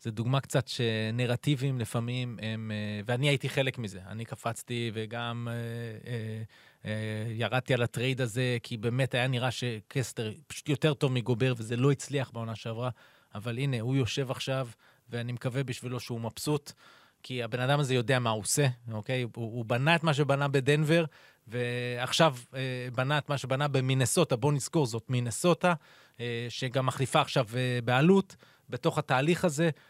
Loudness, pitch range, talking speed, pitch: -30 LUFS, 120-140 Hz, 150 wpm, 125 Hz